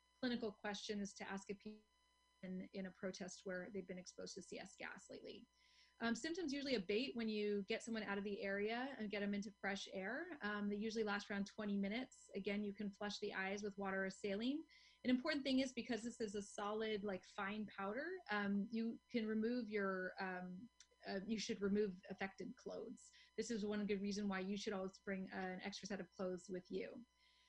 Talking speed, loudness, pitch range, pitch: 205 wpm, -46 LUFS, 195-230 Hz, 205 Hz